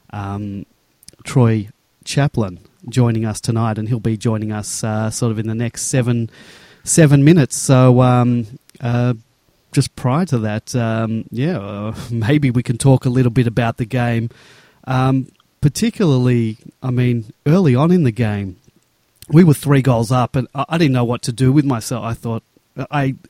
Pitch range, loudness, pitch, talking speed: 115-135 Hz, -17 LUFS, 125 Hz, 175 wpm